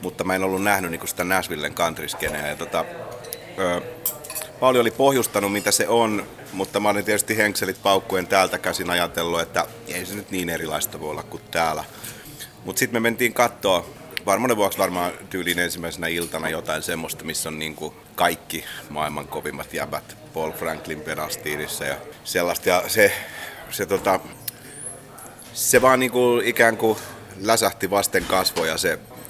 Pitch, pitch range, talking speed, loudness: 100 Hz, 90-115 Hz, 160 wpm, -22 LUFS